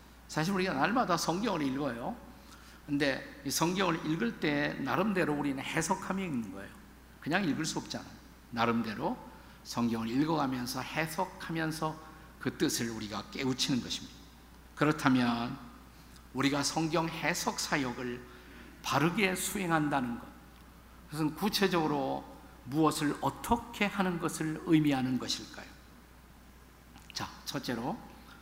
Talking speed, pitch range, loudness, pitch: 275 characters per minute, 125-165 Hz, -32 LUFS, 150 Hz